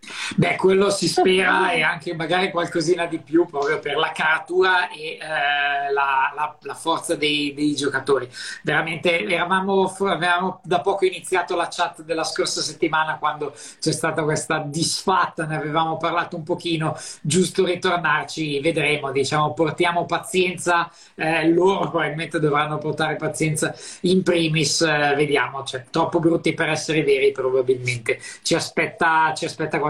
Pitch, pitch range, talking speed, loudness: 165 Hz, 150-175 Hz, 145 wpm, -21 LUFS